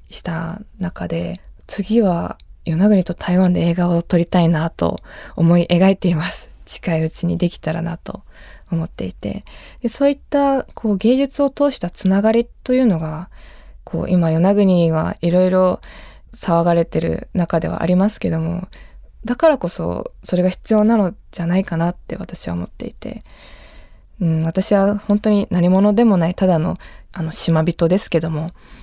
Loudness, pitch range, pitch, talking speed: -18 LUFS, 170-205 Hz, 180 Hz, 300 characters per minute